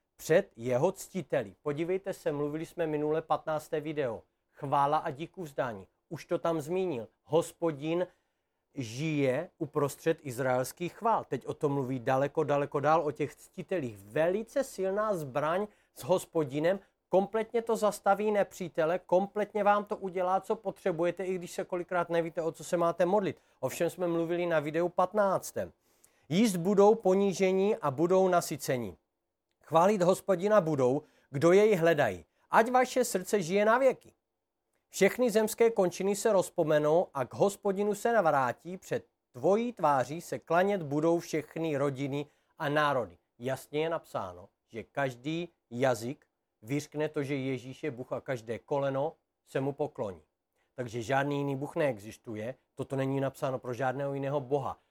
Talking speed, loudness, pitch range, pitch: 145 wpm, -30 LUFS, 140-190 Hz, 165 Hz